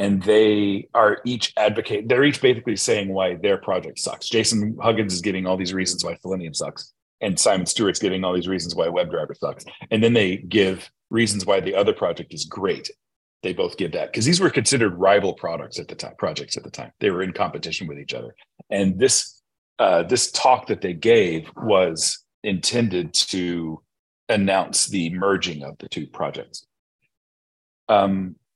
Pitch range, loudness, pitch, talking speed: 90-110 Hz, -21 LUFS, 95 Hz, 185 wpm